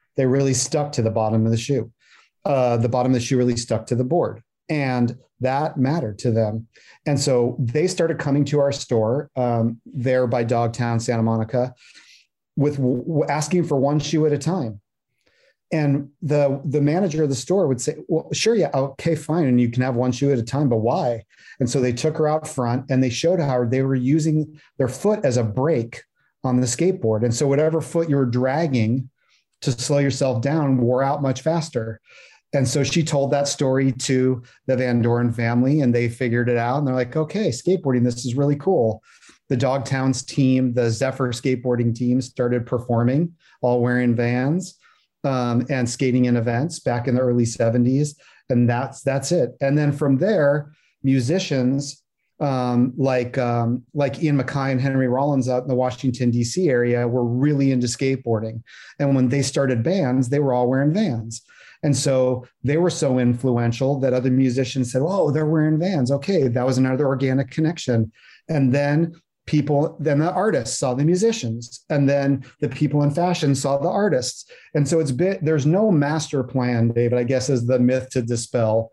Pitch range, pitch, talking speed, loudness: 125-145 Hz, 130 Hz, 190 wpm, -21 LUFS